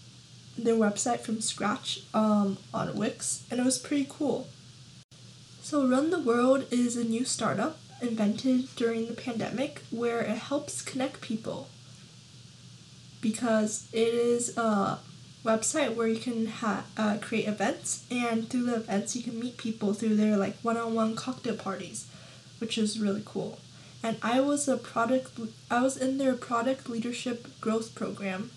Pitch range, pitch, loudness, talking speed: 220-245 Hz, 230 Hz, -30 LUFS, 160 wpm